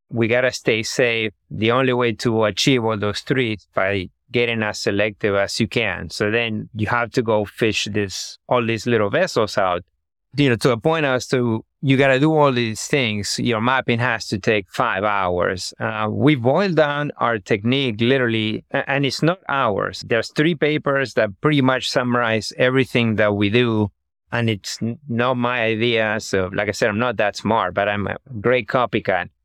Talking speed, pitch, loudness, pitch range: 195 wpm, 115 Hz, -20 LUFS, 105-130 Hz